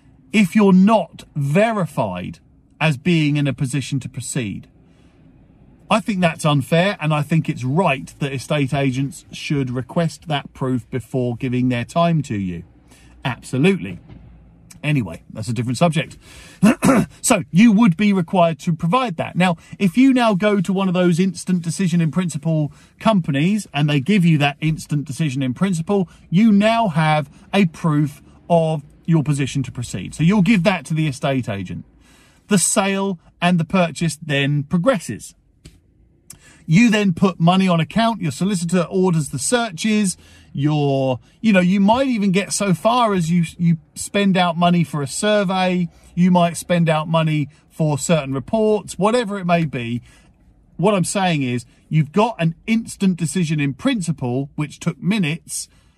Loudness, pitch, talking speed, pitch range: -19 LUFS, 165 Hz, 160 wpm, 145-195 Hz